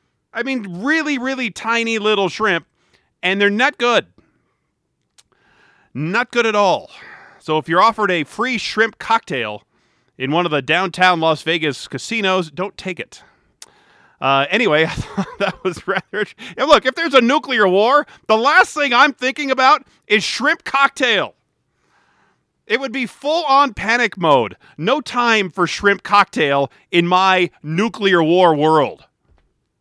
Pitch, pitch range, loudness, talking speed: 205 Hz, 175-255 Hz, -16 LUFS, 145 wpm